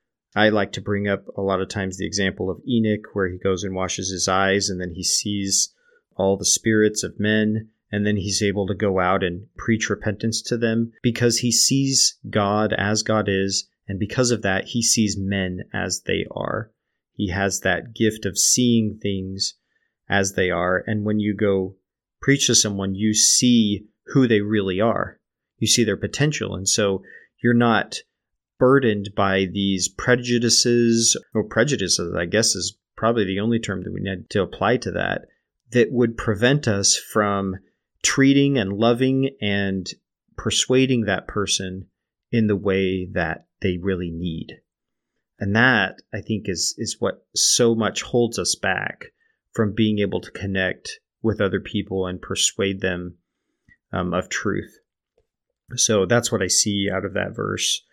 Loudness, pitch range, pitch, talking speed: -21 LUFS, 95-115 Hz, 105 Hz, 170 wpm